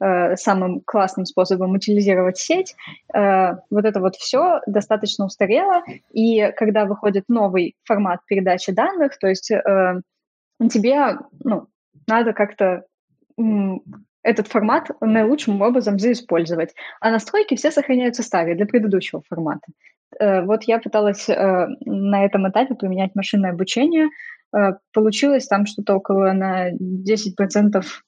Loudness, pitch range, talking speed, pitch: -19 LUFS, 190-230 Hz, 110 wpm, 205 Hz